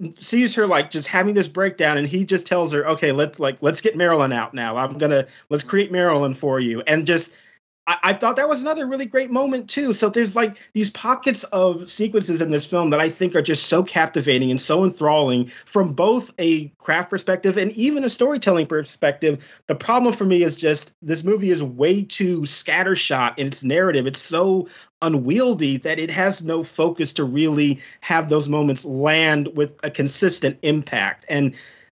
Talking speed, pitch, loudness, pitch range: 190 wpm, 165 Hz, -20 LUFS, 145-195 Hz